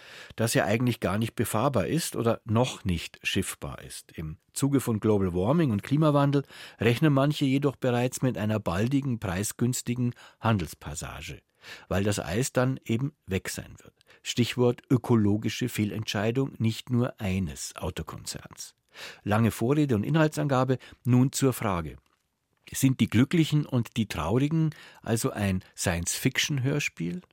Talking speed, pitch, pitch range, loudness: 135 wpm, 120 Hz, 105-135 Hz, -27 LUFS